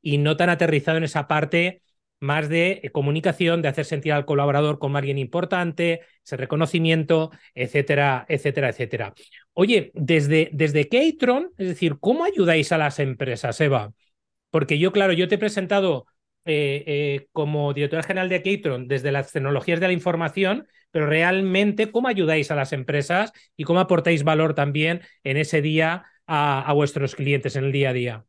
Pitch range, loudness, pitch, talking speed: 145-175 Hz, -22 LUFS, 155 Hz, 170 wpm